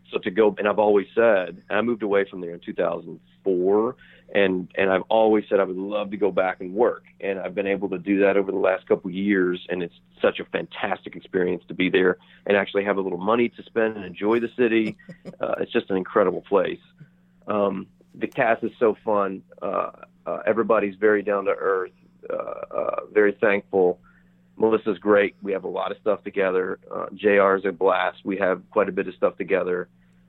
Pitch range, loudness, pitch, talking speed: 95-110 Hz, -23 LUFS, 100 Hz, 210 wpm